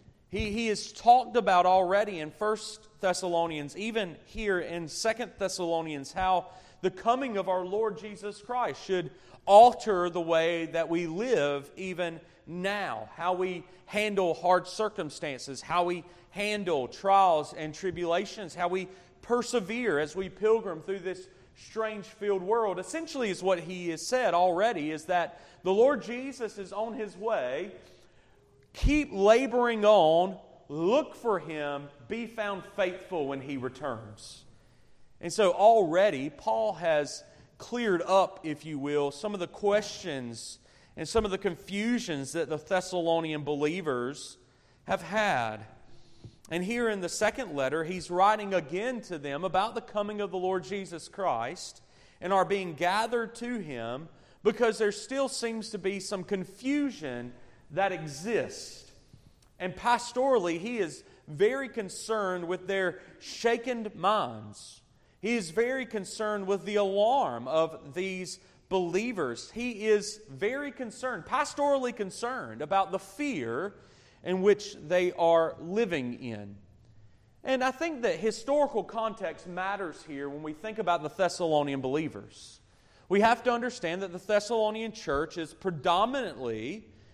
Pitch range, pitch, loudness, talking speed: 165-220 Hz, 185 Hz, -29 LUFS, 140 wpm